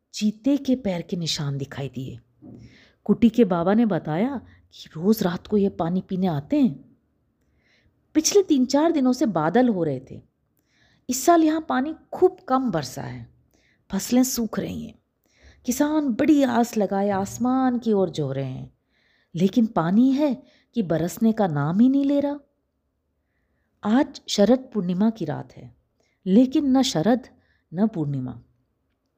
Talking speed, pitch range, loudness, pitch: 150 wpm, 155-255 Hz, -22 LUFS, 205 Hz